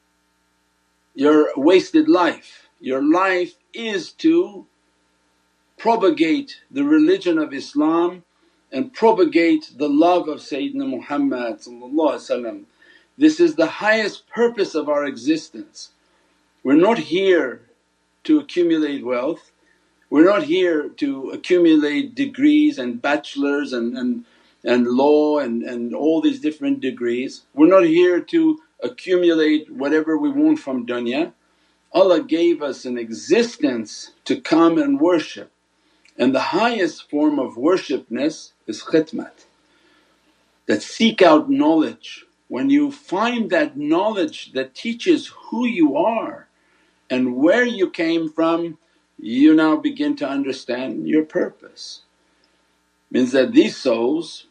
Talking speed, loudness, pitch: 120 wpm, -19 LUFS, 245 Hz